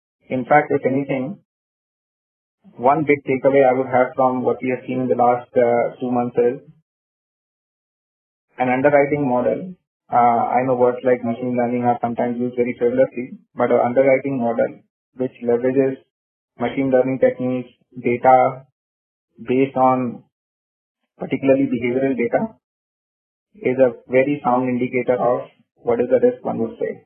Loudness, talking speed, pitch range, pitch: -19 LUFS, 145 wpm, 120-135 Hz, 125 Hz